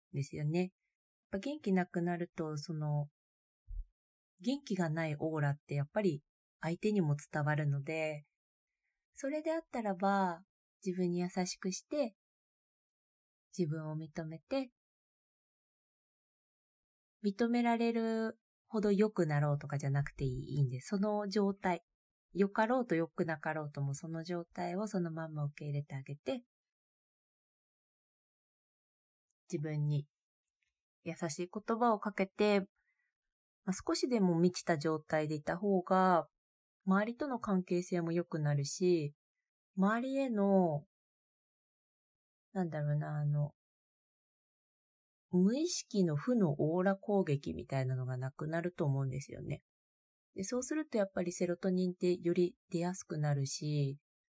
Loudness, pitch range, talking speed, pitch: -36 LUFS, 150-200 Hz, 250 characters per minute, 175 Hz